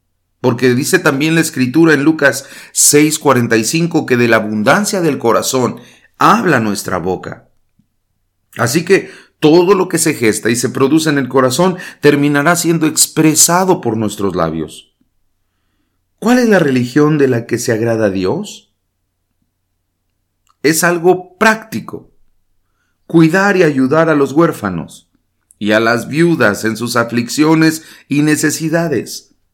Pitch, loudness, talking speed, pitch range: 140 Hz, -12 LUFS, 130 wpm, 110-165 Hz